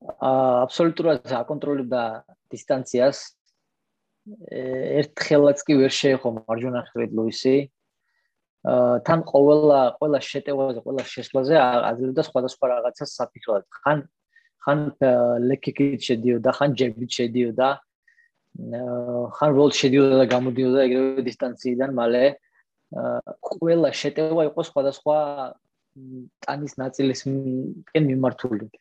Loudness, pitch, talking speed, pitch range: -22 LUFS, 135 Hz, 85 wpm, 125-145 Hz